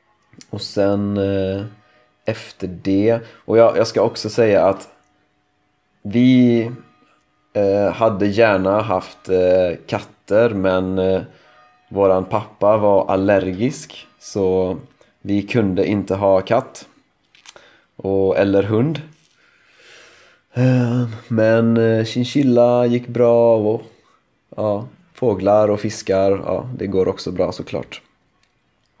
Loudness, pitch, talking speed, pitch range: -18 LUFS, 105 Hz, 105 wpm, 95-115 Hz